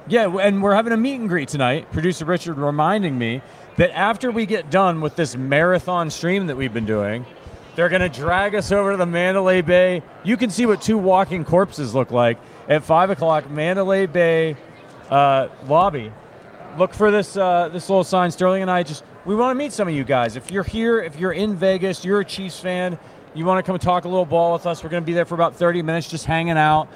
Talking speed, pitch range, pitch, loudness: 225 wpm, 155-195 Hz, 180 Hz, -19 LUFS